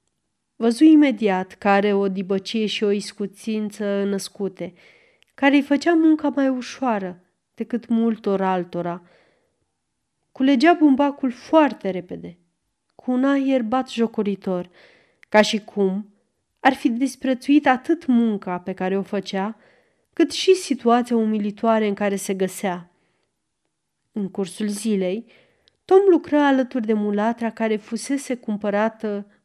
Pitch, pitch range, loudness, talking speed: 220 Hz, 195-265 Hz, -21 LUFS, 120 wpm